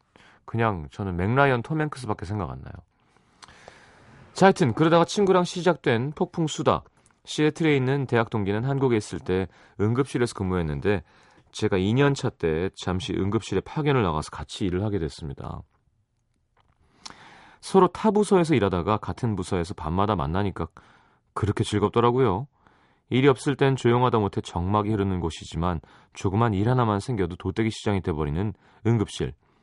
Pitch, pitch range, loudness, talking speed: 110 Hz, 95-135 Hz, -25 LUFS, 340 characters per minute